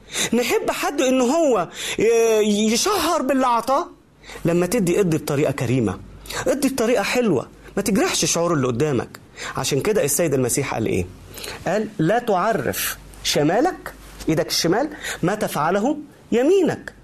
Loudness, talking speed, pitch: -20 LUFS, 125 wpm, 220 Hz